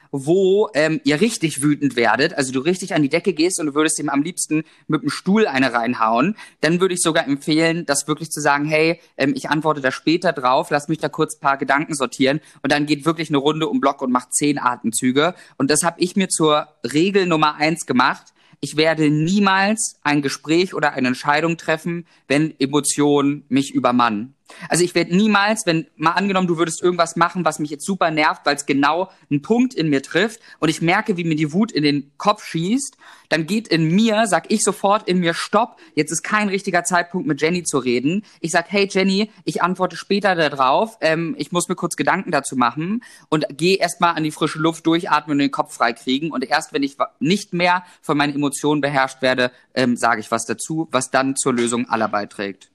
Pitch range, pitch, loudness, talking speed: 140-180 Hz, 155 Hz, -19 LUFS, 215 wpm